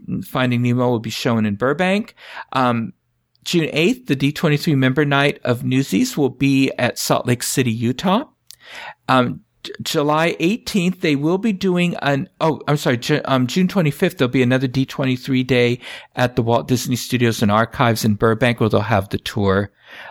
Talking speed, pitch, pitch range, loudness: 175 wpm, 130 Hz, 120-155 Hz, -18 LUFS